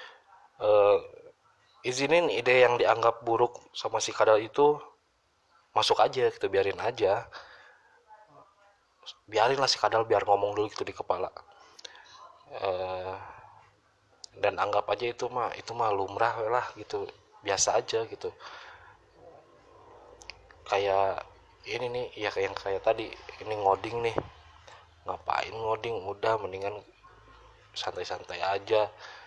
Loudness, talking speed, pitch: -28 LUFS, 115 wpm, 135 Hz